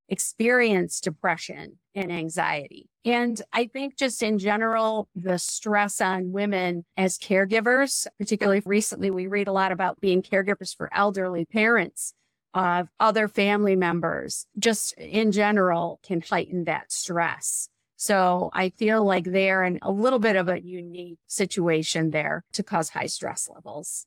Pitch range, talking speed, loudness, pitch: 180-215 Hz, 145 wpm, -24 LUFS, 195 Hz